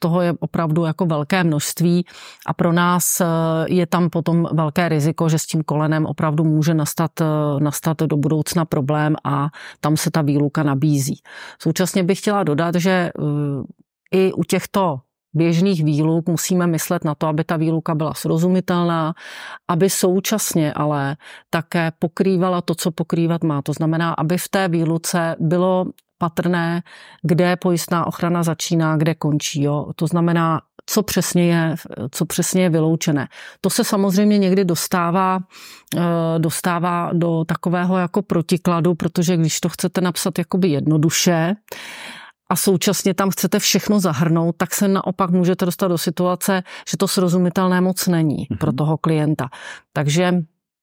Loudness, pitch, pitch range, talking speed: -19 LUFS, 170 Hz, 160-185 Hz, 145 wpm